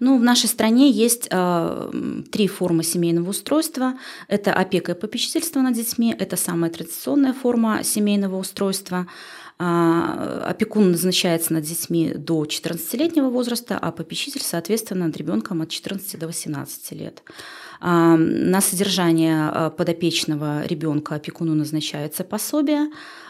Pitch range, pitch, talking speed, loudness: 165-240 Hz, 185 Hz, 125 wpm, -21 LUFS